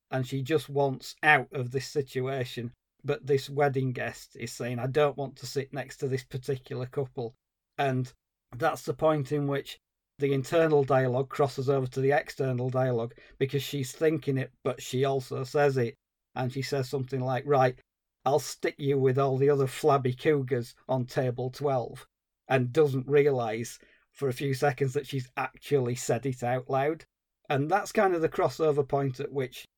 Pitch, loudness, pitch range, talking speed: 135 Hz, -29 LUFS, 130-145 Hz, 180 wpm